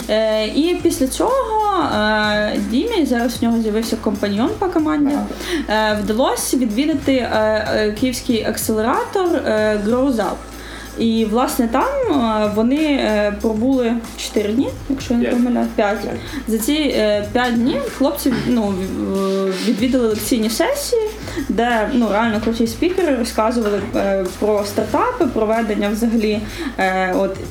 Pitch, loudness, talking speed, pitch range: 235 Hz, -18 LUFS, 115 wpm, 215-280 Hz